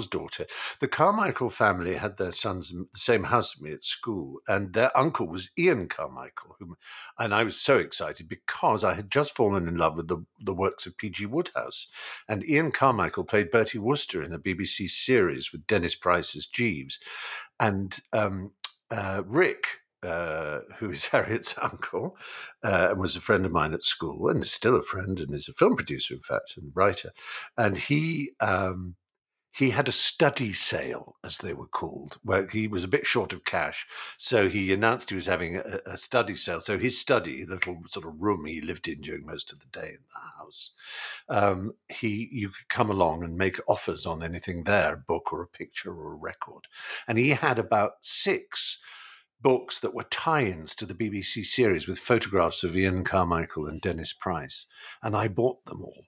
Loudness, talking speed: -27 LUFS, 195 wpm